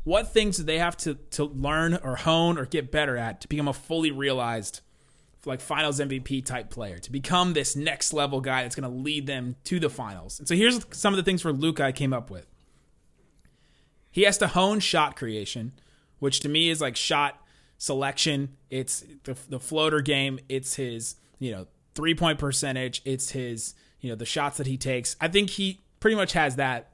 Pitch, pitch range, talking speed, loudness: 140 Hz, 130-160 Hz, 205 wpm, -26 LUFS